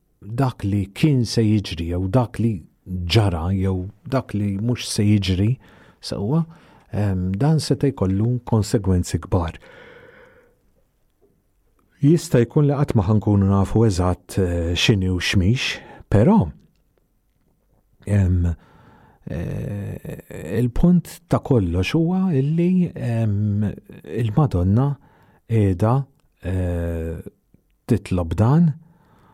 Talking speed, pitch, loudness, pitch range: 100 wpm, 110 Hz, -21 LUFS, 95-135 Hz